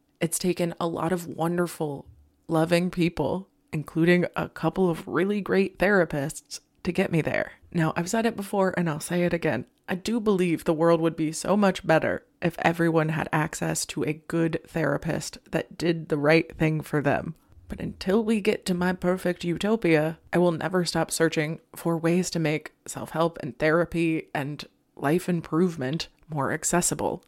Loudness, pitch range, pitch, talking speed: -26 LUFS, 155-180 Hz, 165 Hz, 175 wpm